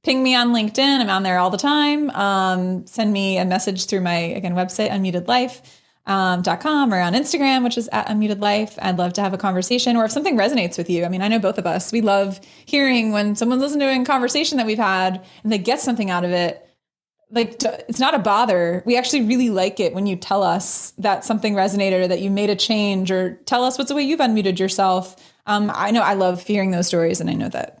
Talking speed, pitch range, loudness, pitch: 240 wpm, 185-245 Hz, -19 LUFS, 205 Hz